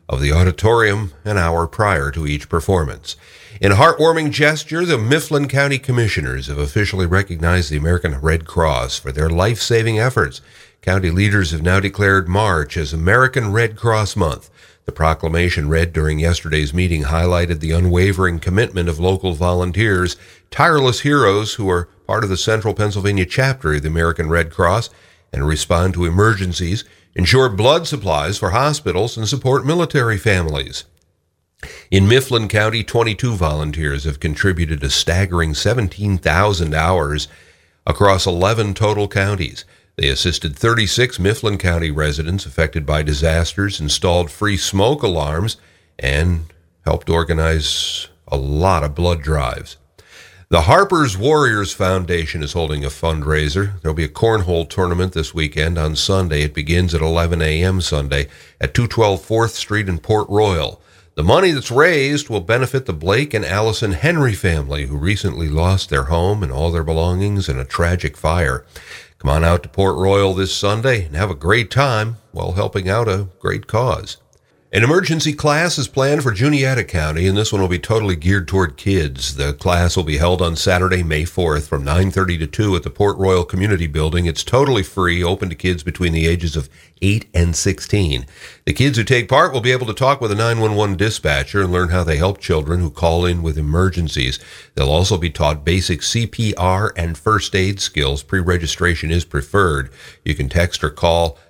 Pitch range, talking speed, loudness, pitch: 80-105 Hz, 165 wpm, -17 LUFS, 90 Hz